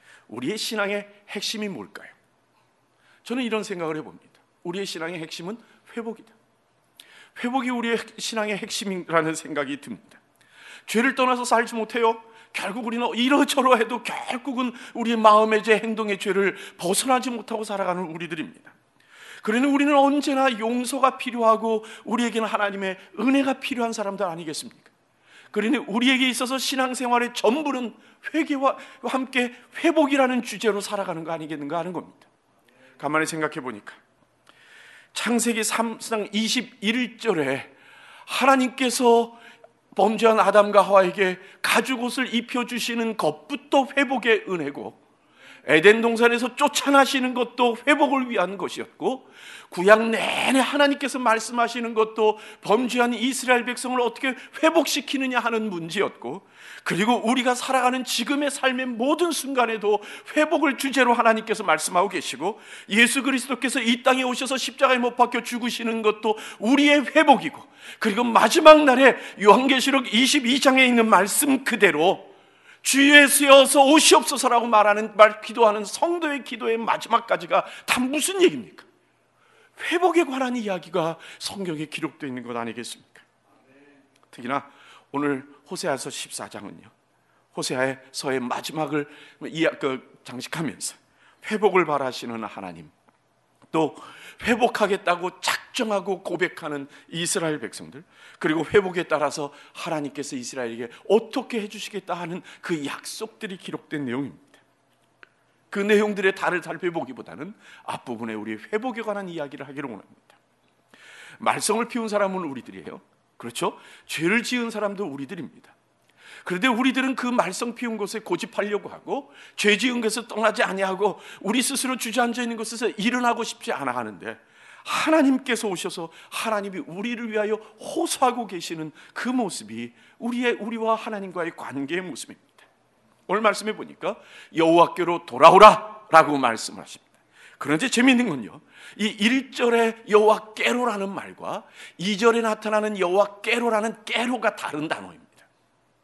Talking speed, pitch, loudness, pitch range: 330 characters per minute, 225 Hz, -22 LUFS, 195-255 Hz